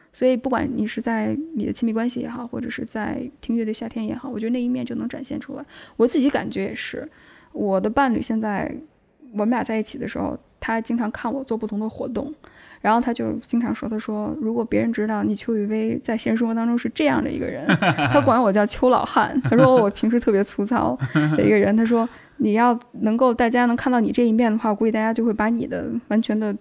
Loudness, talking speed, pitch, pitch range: -22 LUFS, 345 characters per minute, 235 Hz, 220-255 Hz